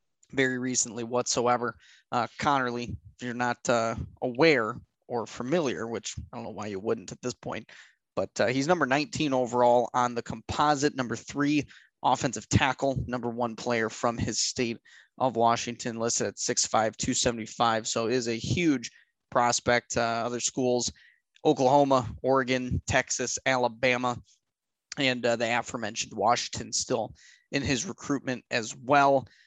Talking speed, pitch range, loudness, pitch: 145 wpm, 115-130 Hz, -27 LUFS, 120 Hz